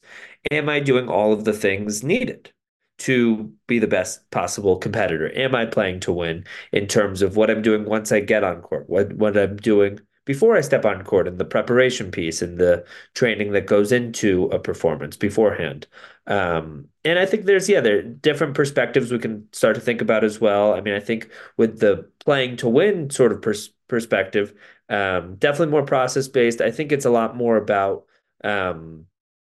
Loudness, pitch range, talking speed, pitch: -20 LUFS, 100-135 Hz, 195 wpm, 110 Hz